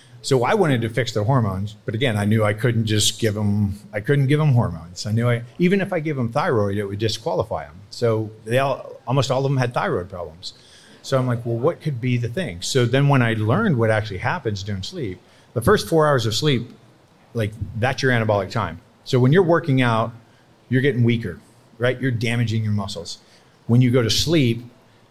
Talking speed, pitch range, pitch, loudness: 220 wpm, 110-135 Hz, 120 Hz, -21 LUFS